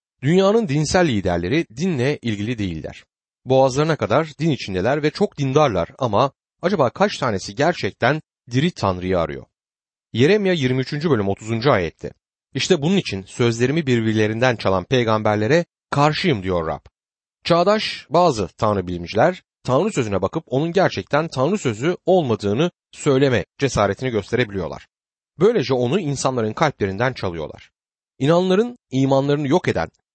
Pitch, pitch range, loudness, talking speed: 130 Hz, 105-160 Hz, -20 LUFS, 120 wpm